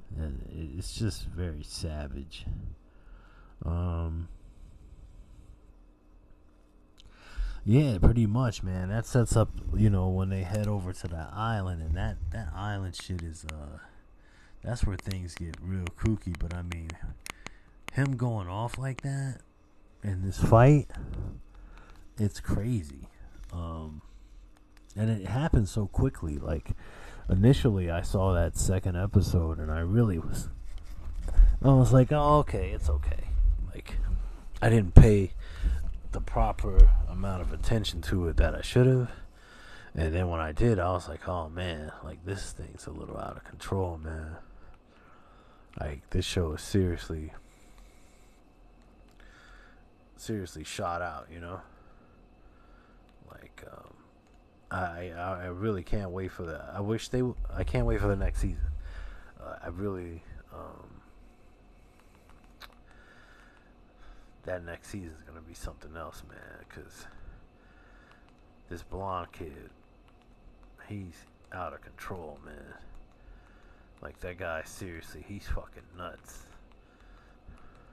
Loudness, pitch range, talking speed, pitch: -30 LUFS, 80-100 Hz, 125 wpm, 90 Hz